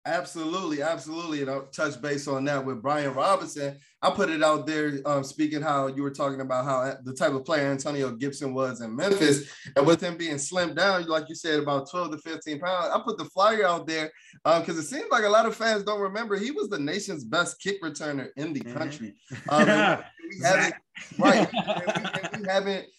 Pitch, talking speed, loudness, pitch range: 155 Hz, 220 wpm, -26 LUFS, 140-180 Hz